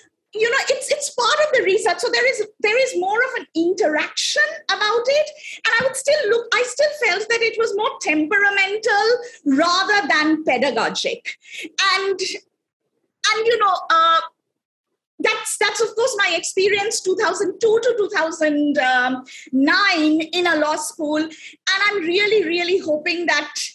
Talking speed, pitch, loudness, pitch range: 150 wpm, 385 Hz, -18 LUFS, 315-440 Hz